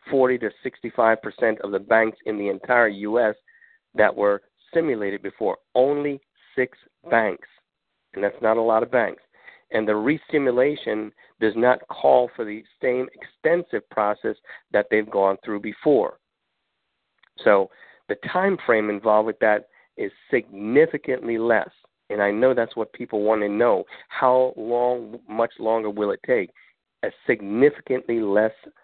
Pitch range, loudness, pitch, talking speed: 105-125 Hz, -23 LUFS, 115 Hz, 145 wpm